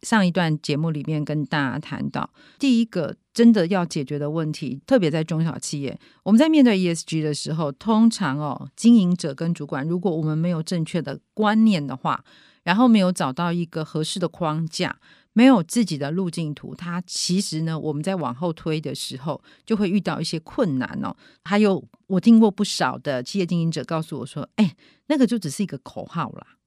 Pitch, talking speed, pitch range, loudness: 170 Hz, 310 characters per minute, 155-205 Hz, -22 LUFS